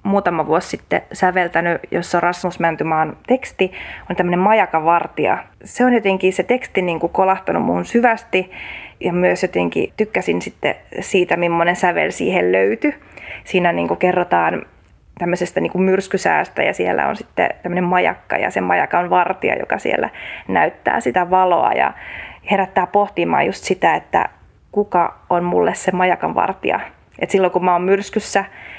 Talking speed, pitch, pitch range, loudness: 150 wpm, 180 Hz, 175-195 Hz, -18 LUFS